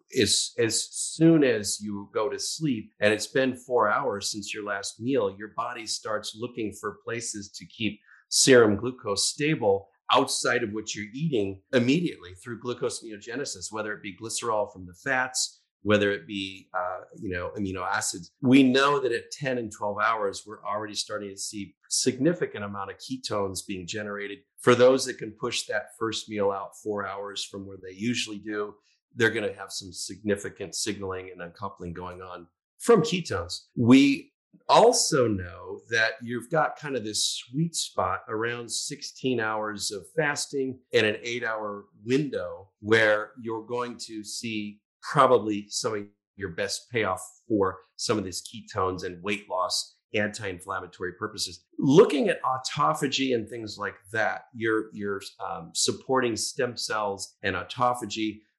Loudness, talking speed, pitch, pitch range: -27 LUFS, 165 wpm, 105 Hz, 100-125 Hz